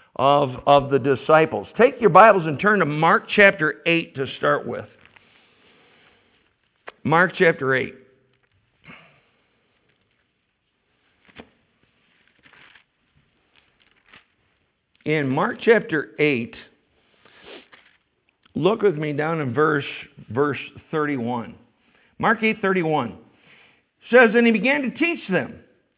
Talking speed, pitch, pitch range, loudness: 95 wpm, 155 Hz, 140-205 Hz, -19 LUFS